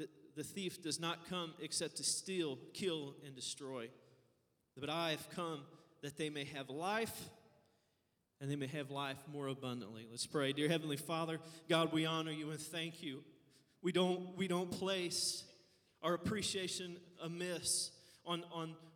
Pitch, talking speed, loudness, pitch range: 160 Hz, 155 wpm, -41 LUFS, 145-175 Hz